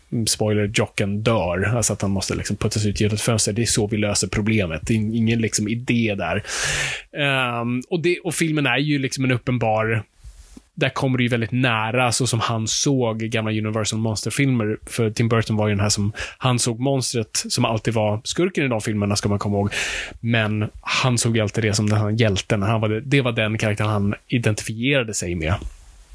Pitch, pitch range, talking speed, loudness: 110 Hz, 105-120 Hz, 205 wpm, -21 LUFS